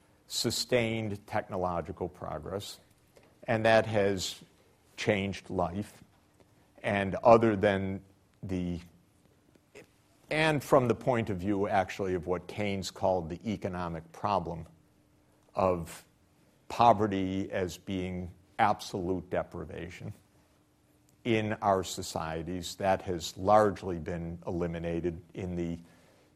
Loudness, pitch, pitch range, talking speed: -31 LUFS, 95 Hz, 90-105 Hz, 95 wpm